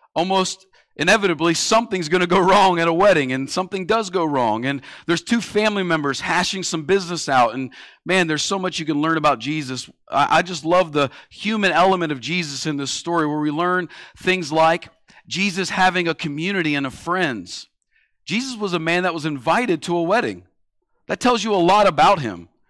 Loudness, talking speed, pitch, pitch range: -19 LUFS, 195 wpm, 170 Hz, 155-190 Hz